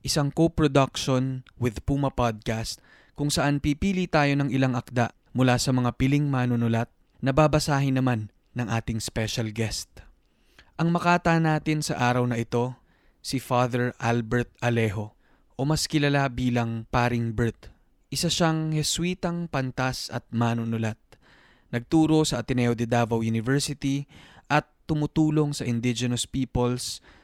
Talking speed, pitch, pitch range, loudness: 130 wpm, 125 Hz, 120-145 Hz, -25 LUFS